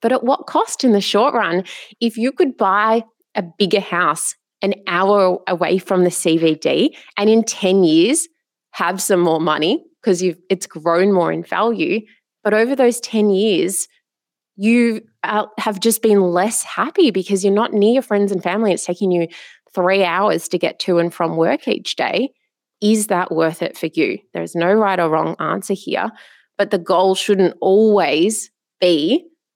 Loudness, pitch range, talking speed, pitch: -17 LUFS, 180-225 Hz, 180 wpm, 200 Hz